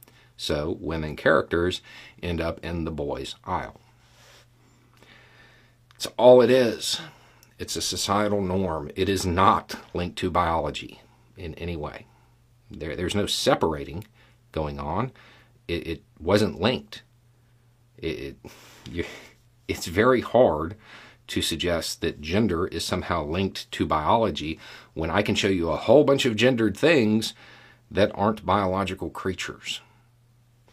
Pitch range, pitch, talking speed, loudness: 90-120 Hz, 105 Hz, 120 wpm, -24 LUFS